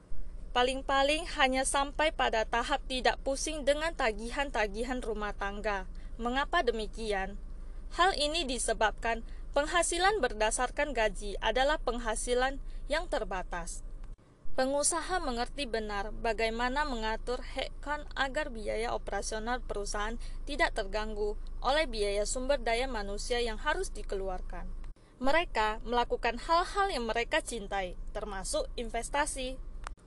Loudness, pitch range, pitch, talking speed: -32 LUFS, 220-285 Hz, 245 Hz, 100 wpm